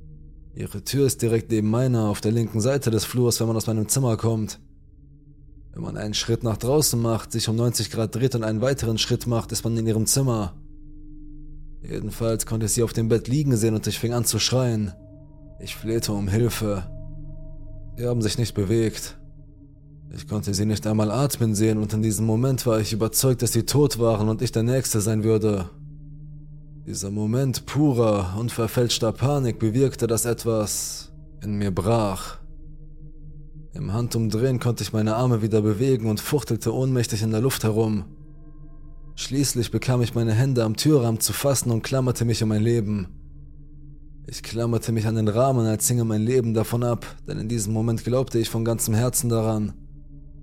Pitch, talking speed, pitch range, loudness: 115 Hz, 180 wpm, 105-125 Hz, -23 LUFS